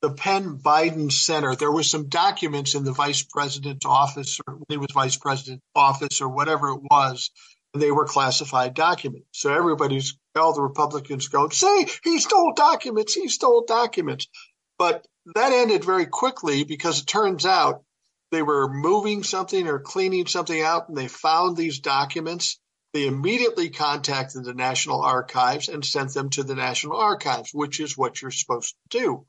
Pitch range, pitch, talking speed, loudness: 140-180 Hz, 150 Hz, 170 wpm, -22 LUFS